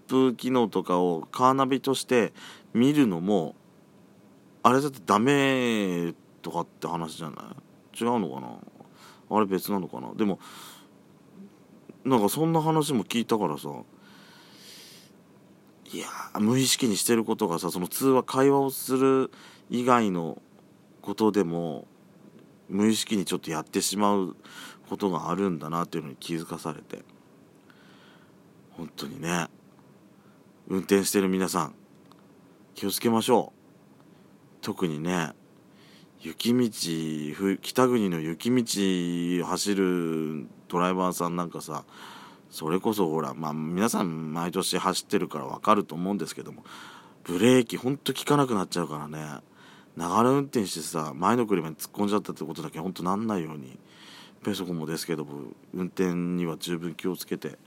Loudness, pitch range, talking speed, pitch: -27 LUFS, 85-115 Hz, 285 characters per minute, 95 Hz